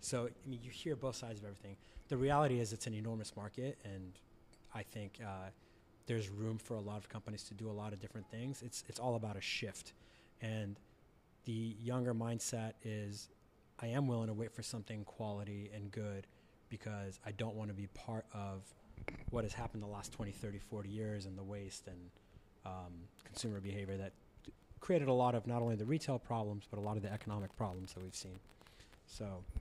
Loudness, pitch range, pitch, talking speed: -43 LUFS, 100-115 Hz, 105 Hz, 205 wpm